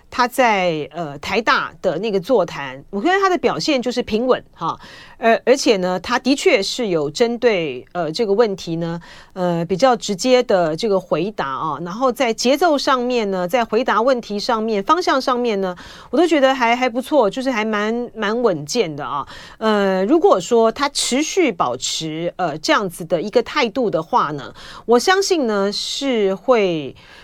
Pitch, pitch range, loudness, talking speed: 225 Hz, 180-255 Hz, -18 LUFS, 255 characters per minute